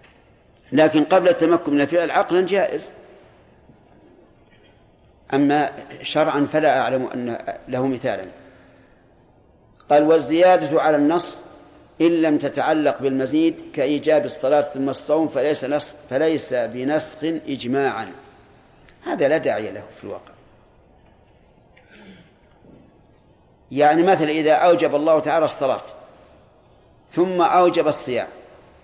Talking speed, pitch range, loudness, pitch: 100 wpm, 145-165 Hz, -19 LUFS, 155 Hz